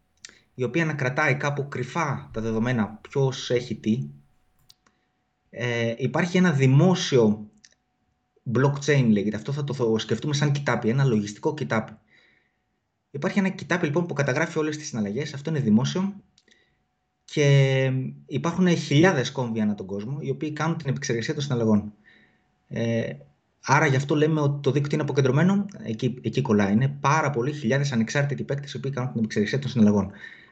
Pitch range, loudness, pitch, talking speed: 115-150 Hz, -24 LUFS, 135 Hz, 155 wpm